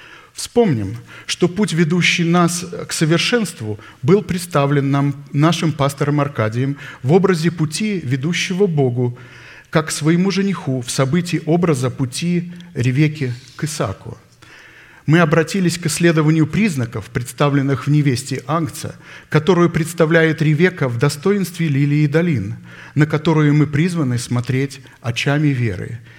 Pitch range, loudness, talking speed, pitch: 135-170 Hz, -17 LUFS, 120 wpm, 155 Hz